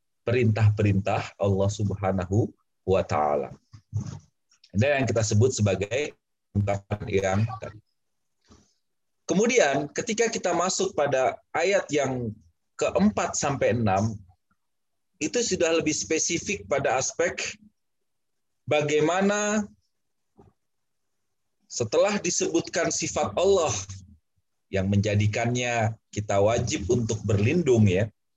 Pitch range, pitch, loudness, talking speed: 100-165 Hz, 115 Hz, -25 LUFS, 85 wpm